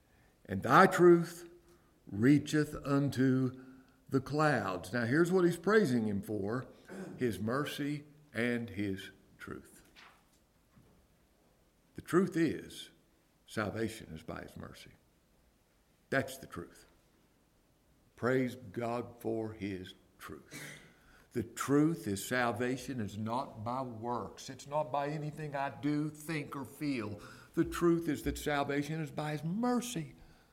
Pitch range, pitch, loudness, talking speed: 115-150 Hz, 135 Hz, -33 LUFS, 120 wpm